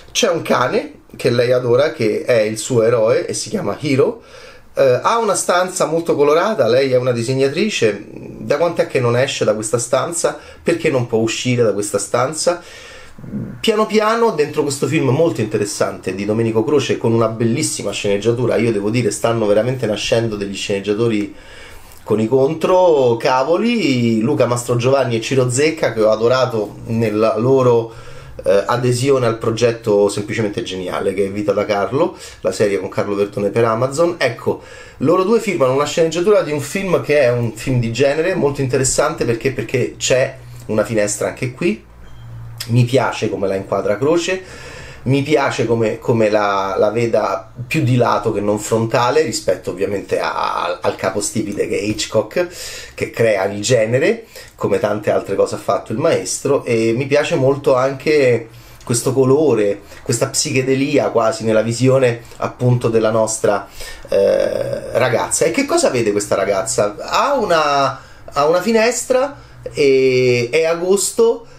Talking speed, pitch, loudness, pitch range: 160 wpm, 125 Hz, -16 LUFS, 110-160 Hz